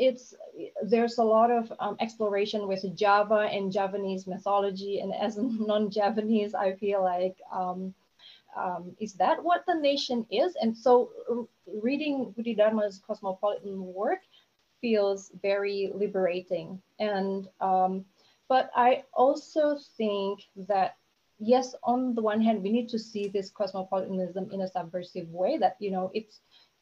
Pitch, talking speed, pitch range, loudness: 205 Hz, 140 wpm, 190-235 Hz, -28 LUFS